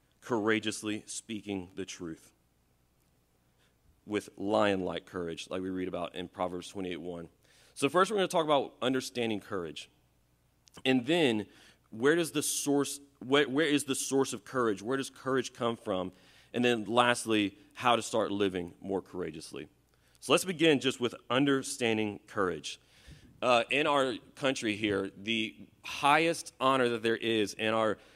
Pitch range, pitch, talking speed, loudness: 95-130 Hz, 110 Hz, 150 wpm, -31 LUFS